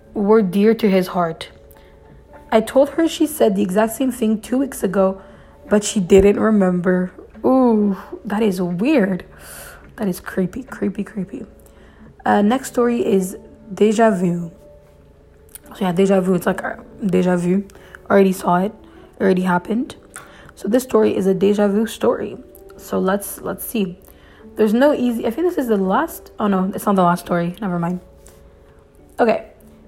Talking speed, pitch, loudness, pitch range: 165 wpm, 200 Hz, -18 LUFS, 185-225 Hz